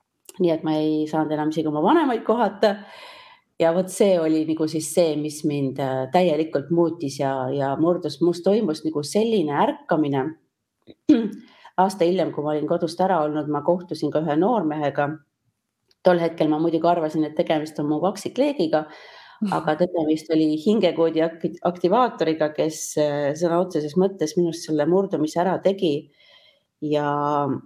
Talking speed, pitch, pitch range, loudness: 145 wpm, 160 Hz, 150-180 Hz, -22 LUFS